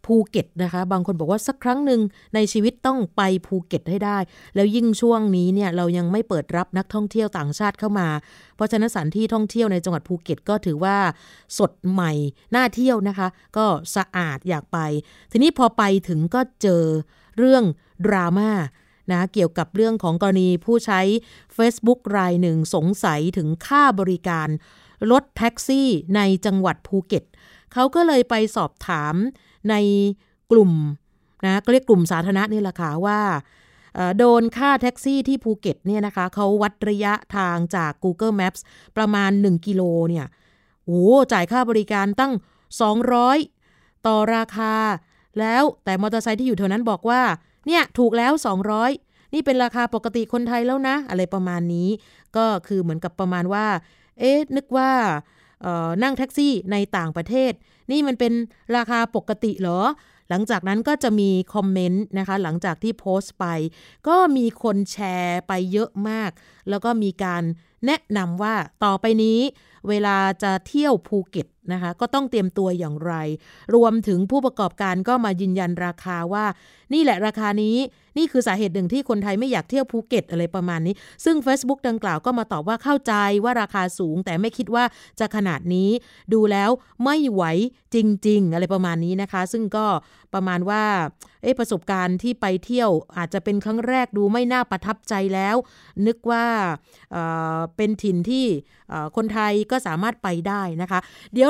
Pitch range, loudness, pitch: 180-235 Hz, -21 LUFS, 205 Hz